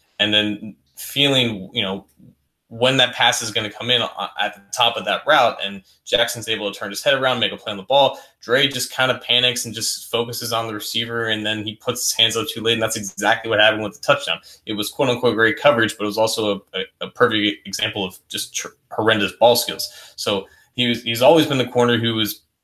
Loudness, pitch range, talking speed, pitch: -19 LUFS, 105-120 Hz, 245 wpm, 115 Hz